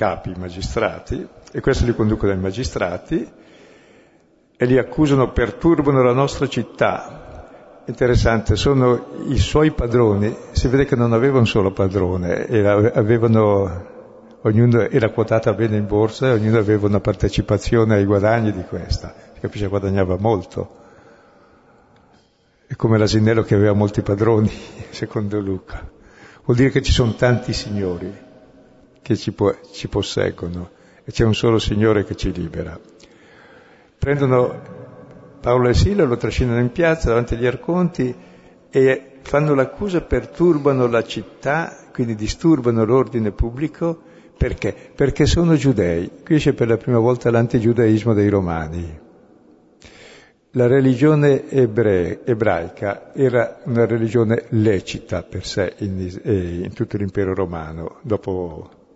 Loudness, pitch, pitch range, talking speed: -18 LUFS, 115 Hz, 100-125 Hz, 130 wpm